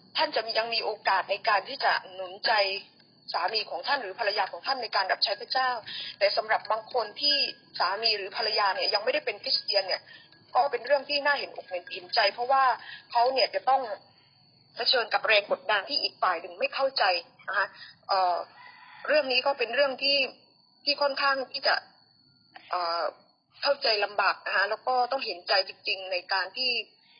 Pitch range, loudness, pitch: 200-275 Hz, -27 LUFS, 245 Hz